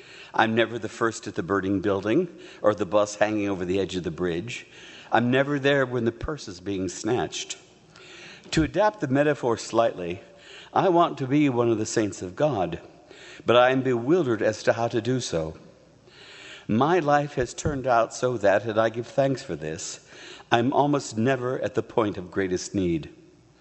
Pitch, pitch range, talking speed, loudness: 115 Hz, 105-135 Hz, 190 wpm, -25 LUFS